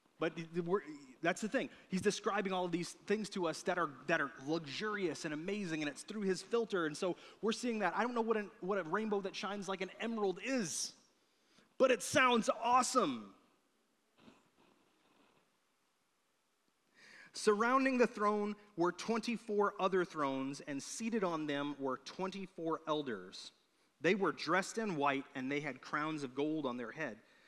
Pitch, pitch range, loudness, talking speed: 195 Hz, 160-225 Hz, -37 LUFS, 165 wpm